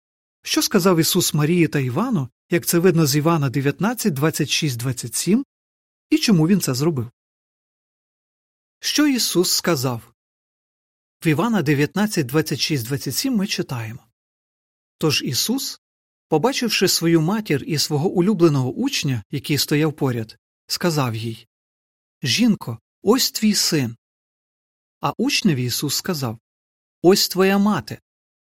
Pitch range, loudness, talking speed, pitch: 130-195 Hz, -20 LUFS, 115 wpm, 160 Hz